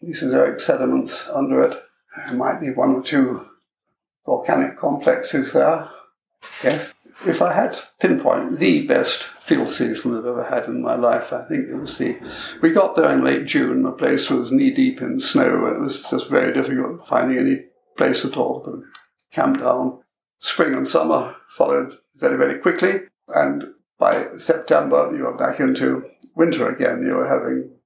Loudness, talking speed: -20 LUFS, 170 wpm